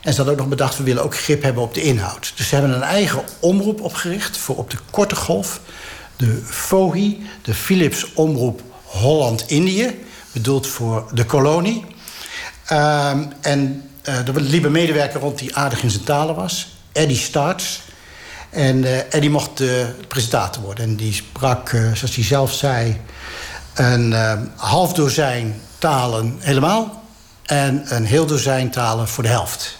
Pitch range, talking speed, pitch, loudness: 120-155 Hz, 165 wpm, 140 Hz, -18 LUFS